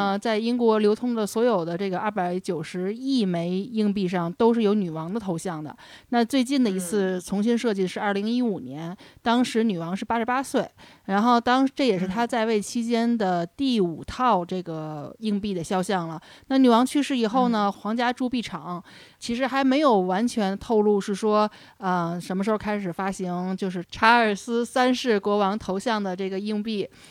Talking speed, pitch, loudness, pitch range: 280 characters per minute, 210 Hz, -24 LUFS, 185-235 Hz